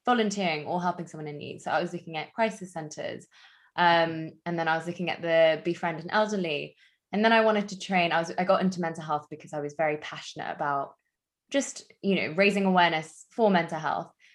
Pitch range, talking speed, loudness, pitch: 160-195 Hz, 215 wpm, -27 LUFS, 175 Hz